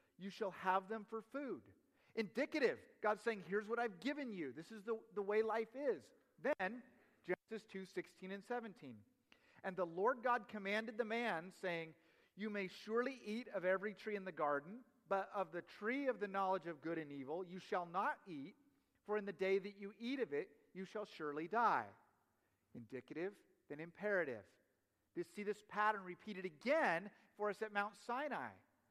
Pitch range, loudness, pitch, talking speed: 185-235 Hz, -43 LUFS, 205 Hz, 180 wpm